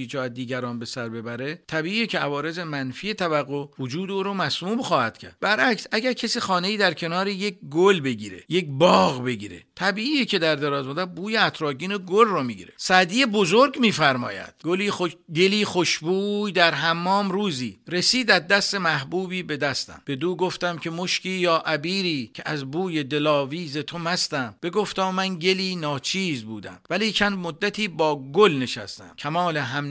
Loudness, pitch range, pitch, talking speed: -23 LUFS, 145-195 Hz, 175 Hz, 165 wpm